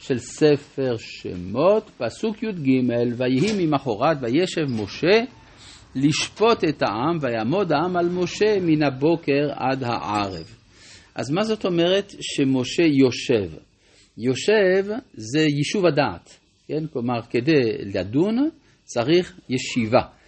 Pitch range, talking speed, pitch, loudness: 120-180 Hz, 105 wpm, 145 Hz, -22 LUFS